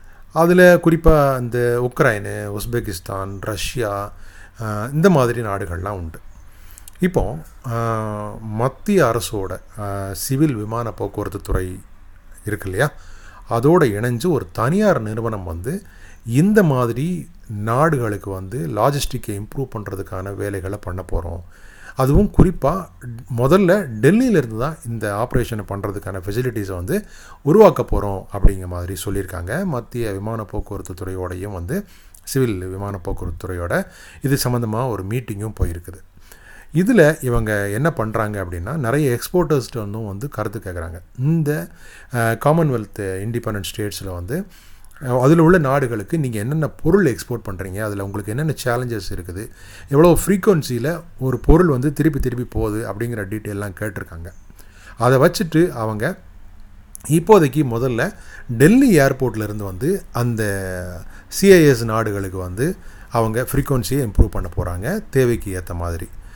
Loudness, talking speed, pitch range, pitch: -19 LUFS, 110 wpm, 95-140 Hz, 110 Hz